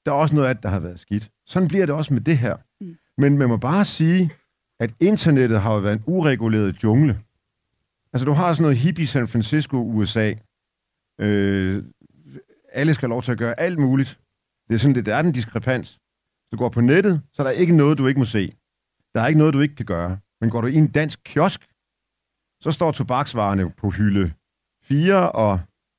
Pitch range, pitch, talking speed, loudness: 105-150 Hz, 125 Hz, 215 wpm, -20 LUFS